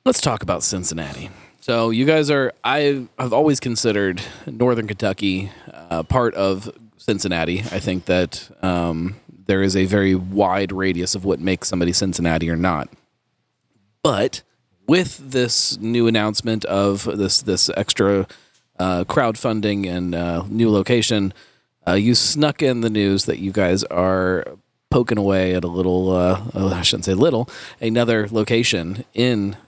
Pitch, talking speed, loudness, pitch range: 100 Hz, 145 wpm, -19 LUFS, 90-115 Hz